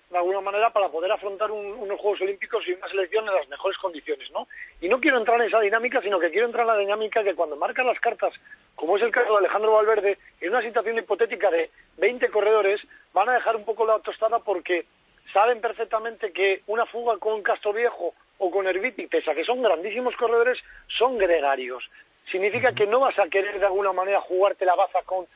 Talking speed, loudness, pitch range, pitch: 210 wpm, -24 LUFS, 195-230 Hz, 215 Hz